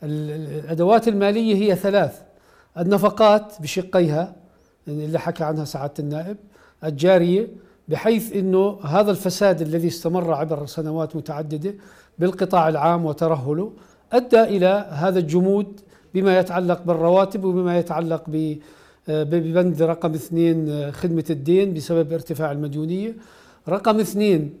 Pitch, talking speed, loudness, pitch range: 175 Hz, 105 wpm, -21 LUFS, 160-195 Hz